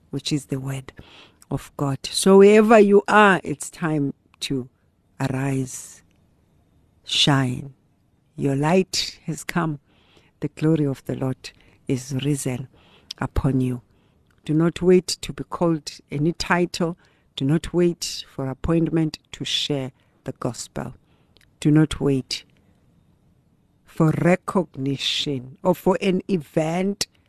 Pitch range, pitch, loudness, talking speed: 130-170 Hz, 145 Hz, -22 LUFS, 120 wpm